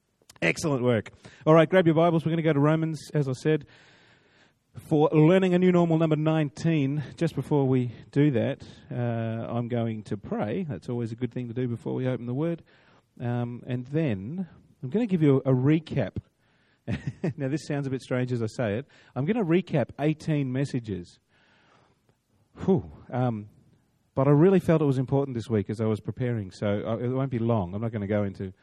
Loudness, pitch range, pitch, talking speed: -26 LUFS, 115-155 Hz, 135 Hz, 205 wpm